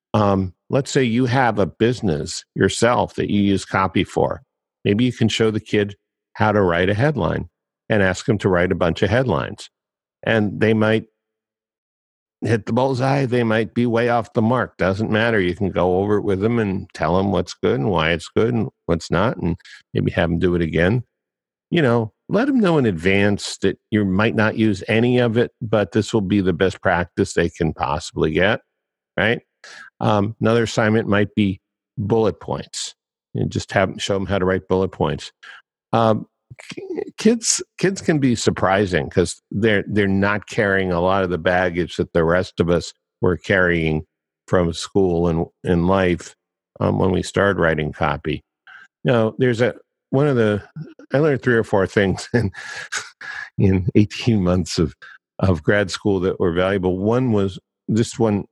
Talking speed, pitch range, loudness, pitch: 185 wpm, 95-115 Hz, -20 LUFS, 105 Hz